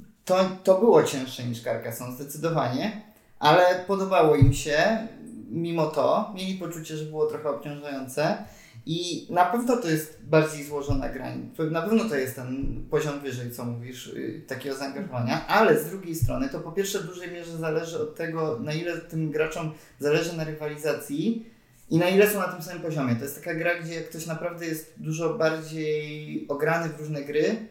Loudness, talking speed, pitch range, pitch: -26 LUFS, 175 wpm, 145-175 Hz, 160 Hz